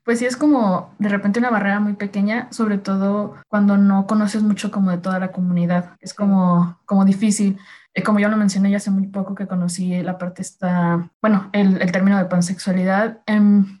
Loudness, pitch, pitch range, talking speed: -19 LUFS, 195 Hz, 185-210 Hz, 195 wpm